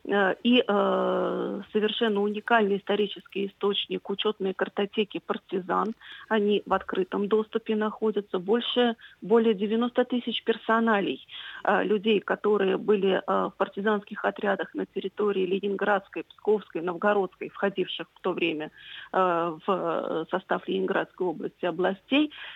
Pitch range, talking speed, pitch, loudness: 185-220 Hz, 100 wpm, 200 Hz, -27 LUFS